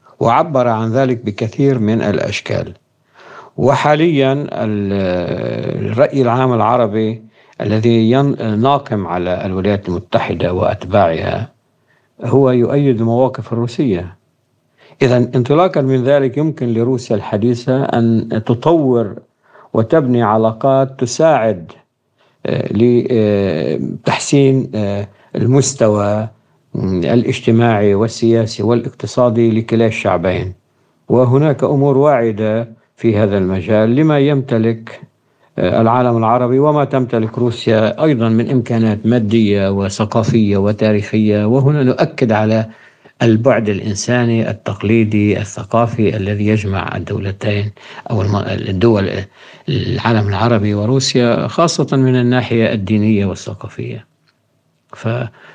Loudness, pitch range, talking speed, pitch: -14 LUFS, 105-130 Hz, 85 wpm, 115 Hz